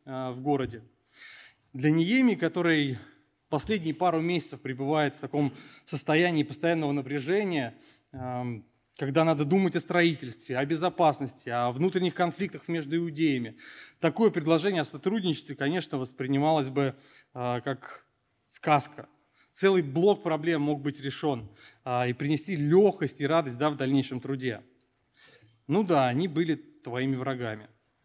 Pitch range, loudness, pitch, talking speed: 130-165 Hz, -28 LUFS, 145 Hz, 120 wpm